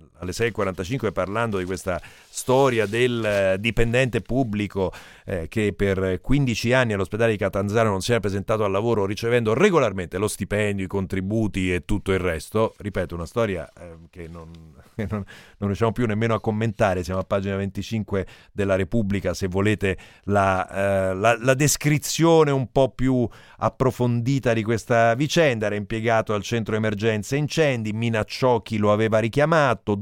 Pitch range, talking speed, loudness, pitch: 95-115 Hz, 160 wpm, -23 LUFS, 105 Hz